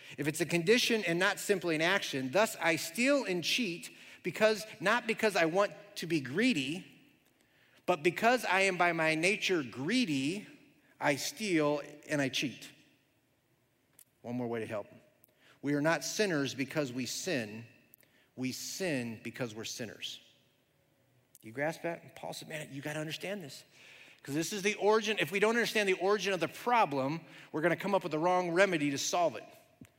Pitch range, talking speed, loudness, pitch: 140-200 Hz, 175 wpm, -32 LUFS, 165 Hz